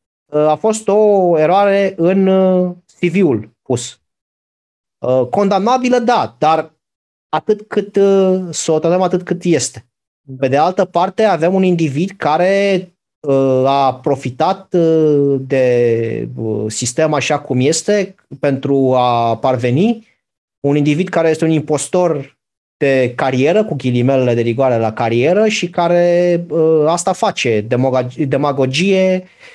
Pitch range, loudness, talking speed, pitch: 130-185 Hz, -14 LUFS, 110 wpm, 155 Hz